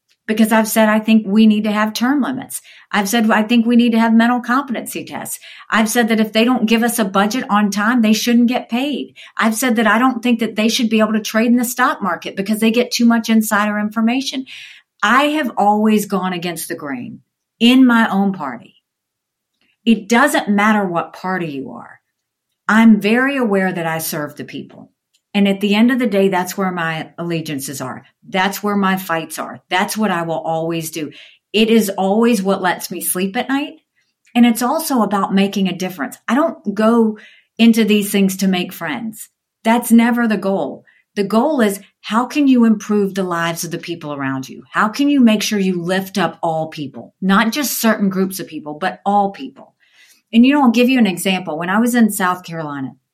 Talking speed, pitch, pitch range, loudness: 210 wpm, 210 Hz, 185-230 Hz, -16 LUFS